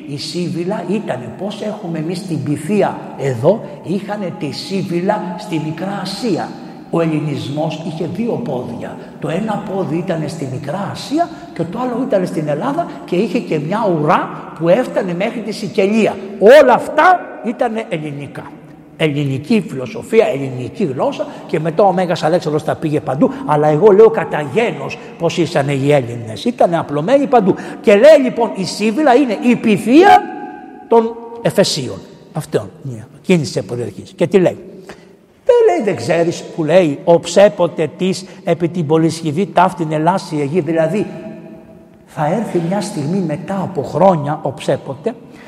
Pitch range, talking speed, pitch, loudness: 155-210 Hz, 150 wpm, 180 Hz, -15 LUFS